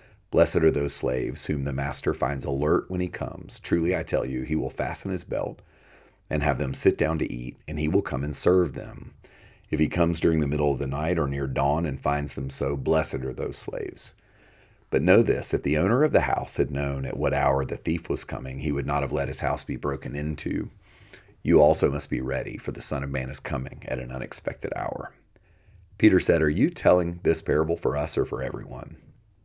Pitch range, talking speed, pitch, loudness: 70-85 Hz, 225 wpm, 75 Hz, -25 LUFS